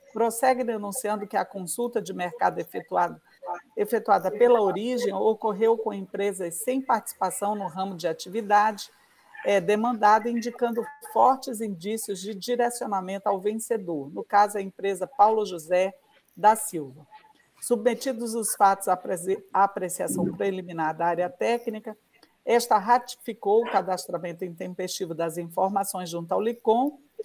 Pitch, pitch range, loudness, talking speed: 210 Hz, 190-235 Hz, -26 LUFS, 125 wpm